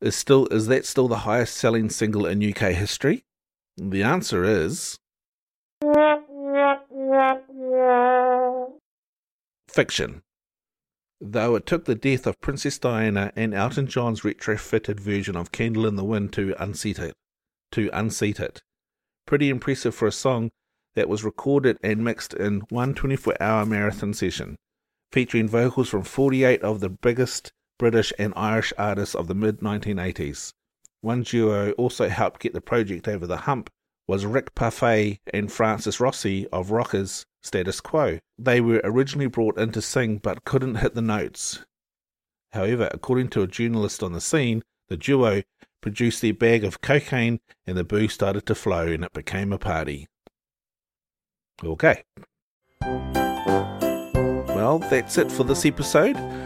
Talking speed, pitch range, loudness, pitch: 145 wpm, 100-130 Hz, -24 LUFS, 110 Hz